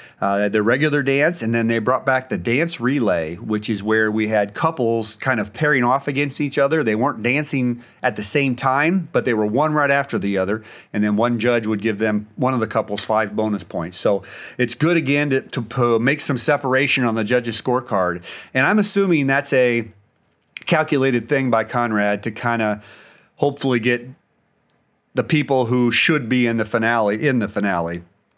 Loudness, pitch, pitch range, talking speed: -19 LUFS, 120 Hz, 110-140 Hz, 195 wpm